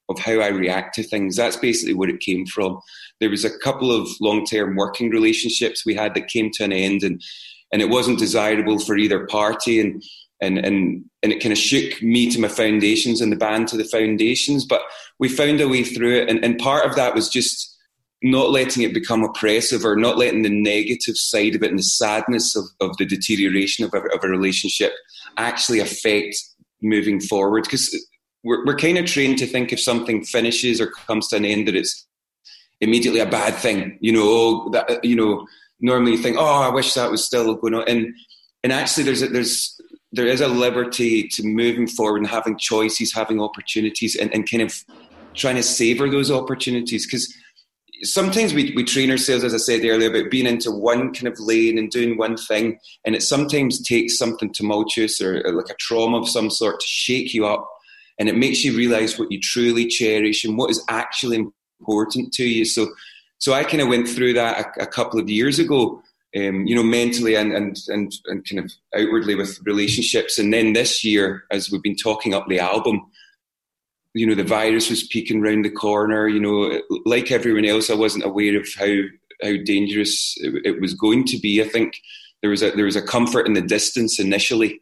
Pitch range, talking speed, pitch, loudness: 105-120 Hz, 210 wpm, 110 Hz, -19 LUFS